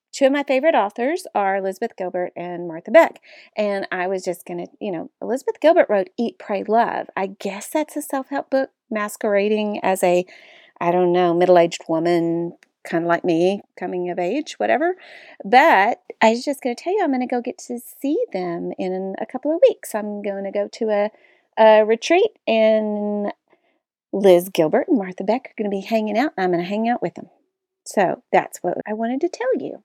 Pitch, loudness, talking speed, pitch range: 215 Hz, -20 LUFS, 210 wpm, 185-285 Hz